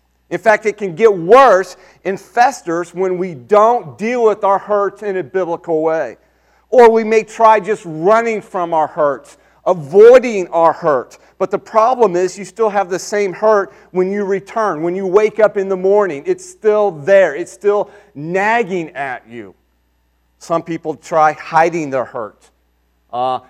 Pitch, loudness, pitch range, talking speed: 190 Hz, -14 LUFS, 165-215 Hz, 170 wpm